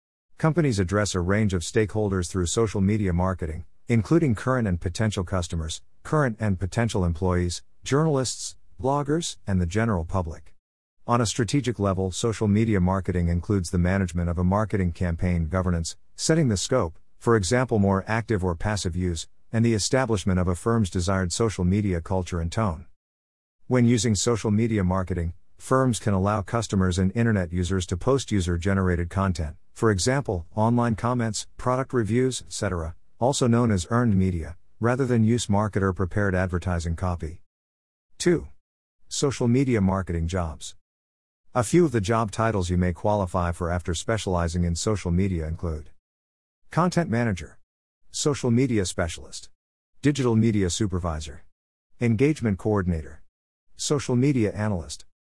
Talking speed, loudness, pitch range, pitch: 145 wpm, -25 LUFS, 85-115 Hz, 95 Hz